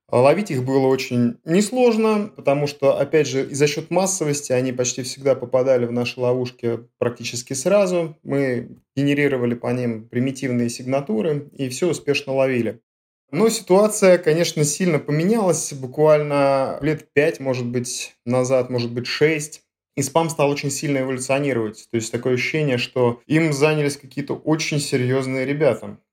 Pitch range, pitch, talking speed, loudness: 125-155 Hz, 135 Hz, 145 wpm, -20 LUFS